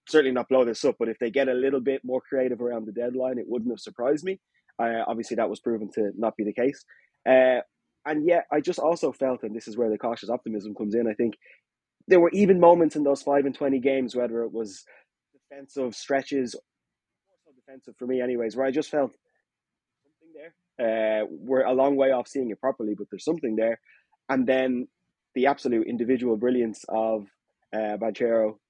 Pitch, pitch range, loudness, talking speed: 125 Hz, 115-135 Hz, -25 LUFS, 205 wpm